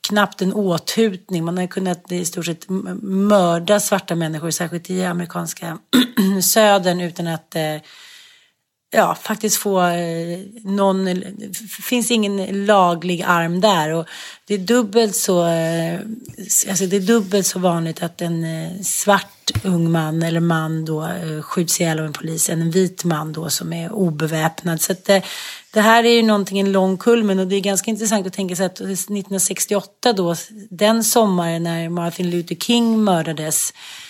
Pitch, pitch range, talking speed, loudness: 185 Hz, 170-205 Hz, 155 wpm, -18 LUFS